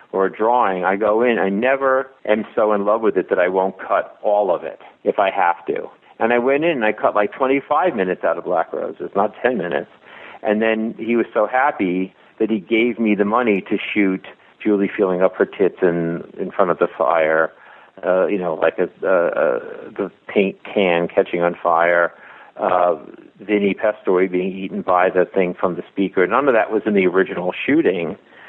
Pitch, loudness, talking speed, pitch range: 100 Hz, -19 LUFS, 210 wpm, 95-110 Hz